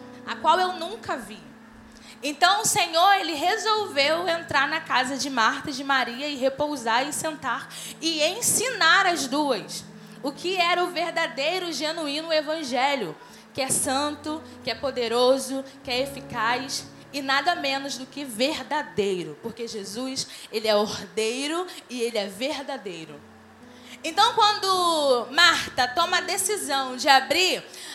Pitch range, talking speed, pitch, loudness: 245-330 Hz, 140 wpm, 280 Hz, -24 LUFS